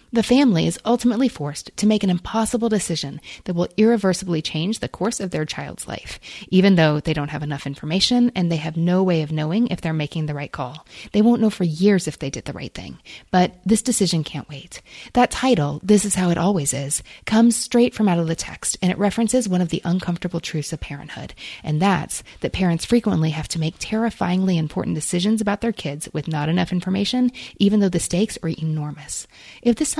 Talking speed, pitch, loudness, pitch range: 215 wpm, 180 Hz, -21 LUFS, 155-215 Hz